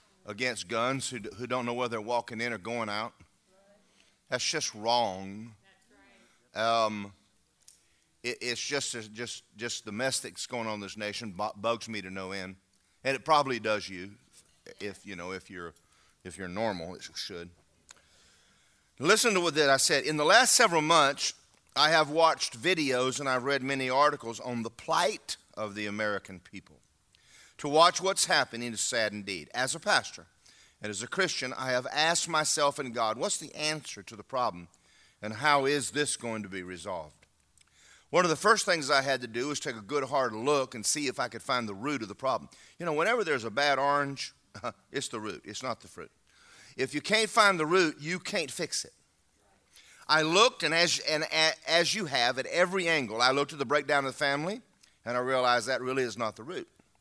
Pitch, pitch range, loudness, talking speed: 120 Hz, 105-150 Hz, -28 LUFS, 200 wpm